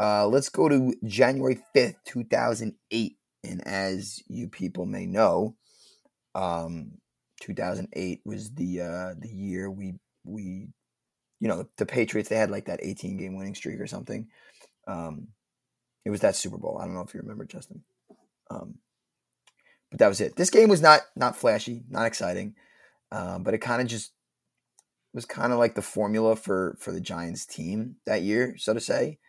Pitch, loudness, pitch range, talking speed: 105 Hz, -26 LUFS, 95-120 Hz, 175 wpm